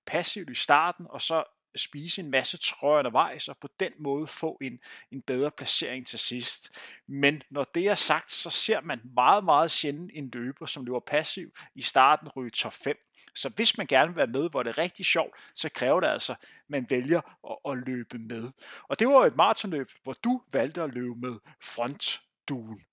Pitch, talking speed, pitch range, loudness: 140 Hz, 200 wpm, 125-160 Hz, -27 LUFS